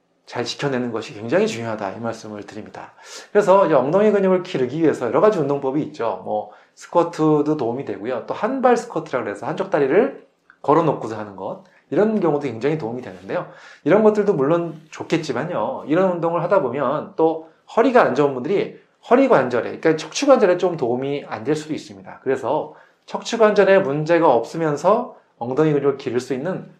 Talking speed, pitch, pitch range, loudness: 400 characters per minute, 160 Hz, 135-190 Hz, -20 LUFS